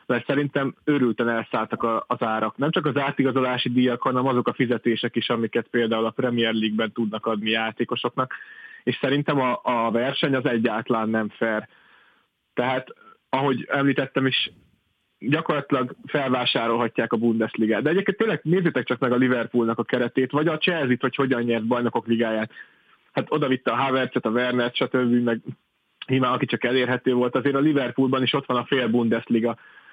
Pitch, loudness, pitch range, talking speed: 125 Hz, -23 LUFS, 115-135 Hz, 165 wpm